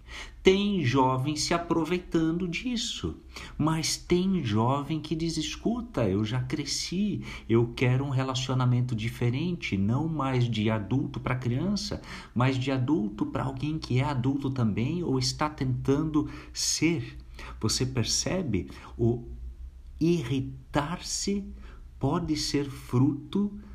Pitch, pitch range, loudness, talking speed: 135 Hz, 120-160 Hz, -28 LUFS, 115 wpm